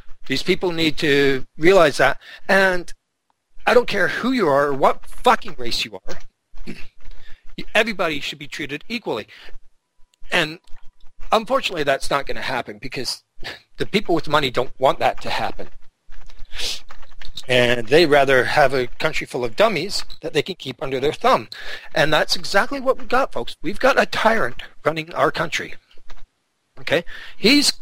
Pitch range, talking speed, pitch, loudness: 140-210 Hz, 160 wpm, 170 Hz, -20 LUFS